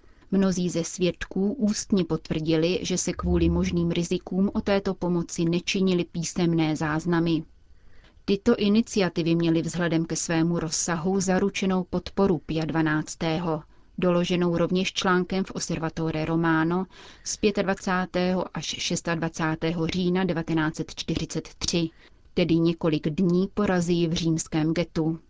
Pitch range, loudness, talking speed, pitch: 160-185 Hz, -25 LUFS, 110 wpm, 170 Hz